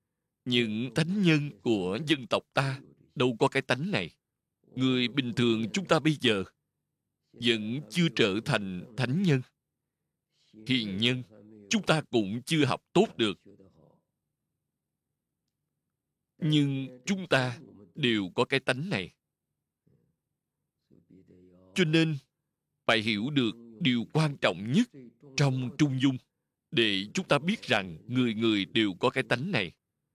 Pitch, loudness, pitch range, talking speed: 130 Hz, -28 LUFS, 115-155 Hz, 130 wpm